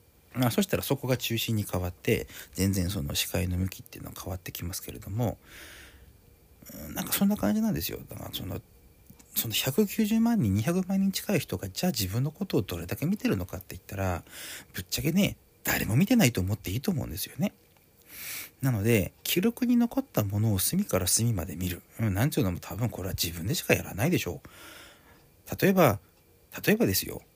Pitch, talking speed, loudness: 105 Hz, 390 characters per minute, -28 LUFS